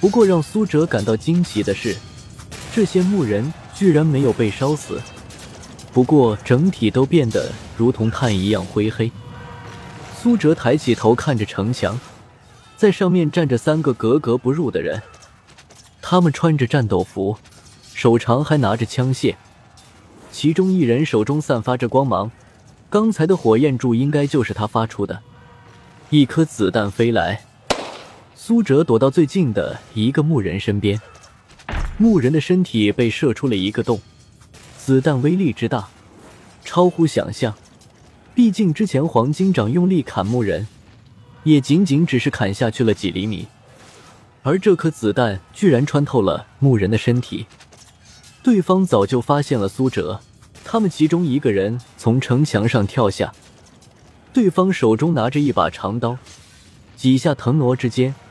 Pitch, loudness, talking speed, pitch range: 125 Hz, -18 LUFS, 220 characters per minute, 110-155 Hz